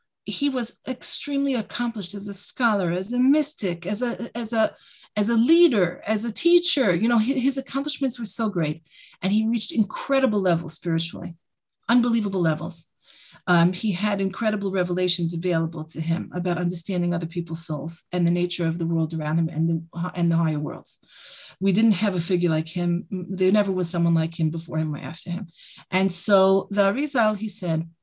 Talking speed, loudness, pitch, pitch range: 185 wpm, -23 LUFS, 185 Hz, 170-220 Hz